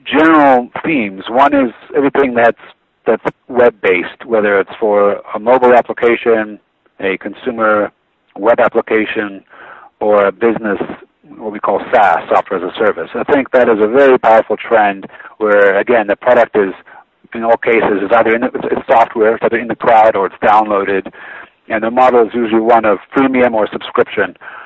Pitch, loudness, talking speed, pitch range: 115 Hz, -12 LUFS, 170 wpm, 105-125 Hz